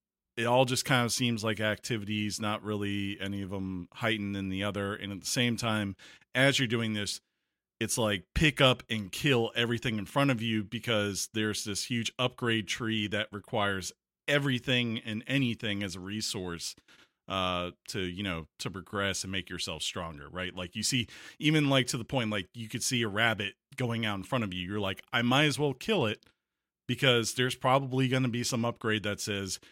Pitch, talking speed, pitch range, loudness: 110 Hz, 200 wpm, 100-125 Hz, -30 LUFS